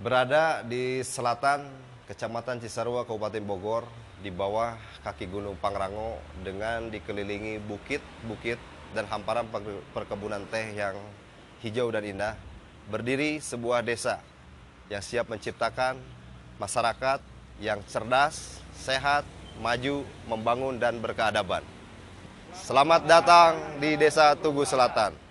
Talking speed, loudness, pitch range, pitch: 100 wpm, -27 LUFS, 100-130 Hz, 115 Hz